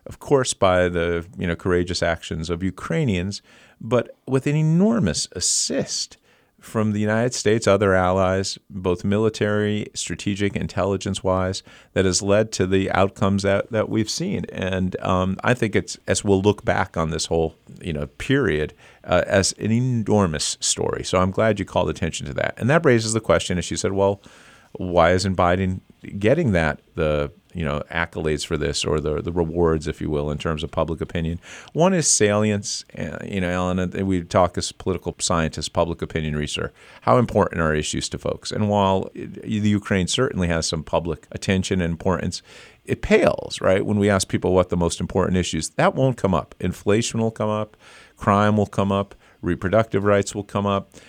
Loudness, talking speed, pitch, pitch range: -22 LUFS, 185 wpm, 95 Hz, 85-105 Hz